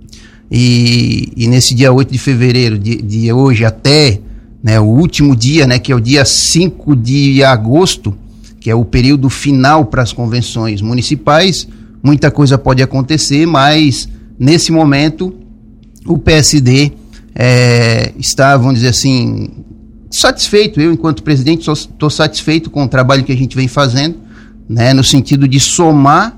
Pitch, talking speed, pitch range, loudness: 130 Hz, 150 wpm, 115-145 Hz, -9 LUFS